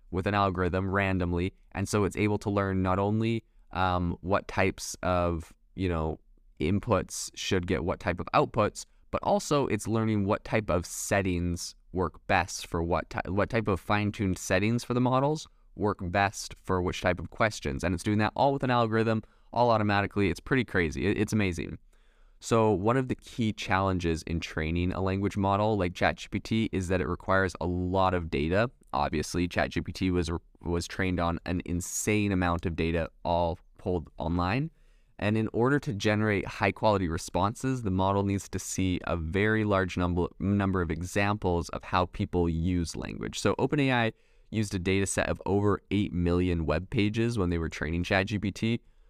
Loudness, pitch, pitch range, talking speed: -29 LUFS, 95 Hz, 85-105 Hz, 175 wpm